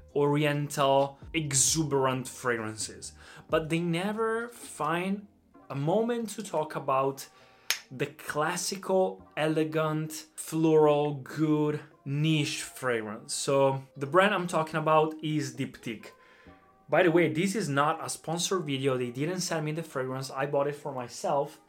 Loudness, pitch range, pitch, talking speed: -29 LUFS, 140-165 Hz, 155 Hz, 130 wpm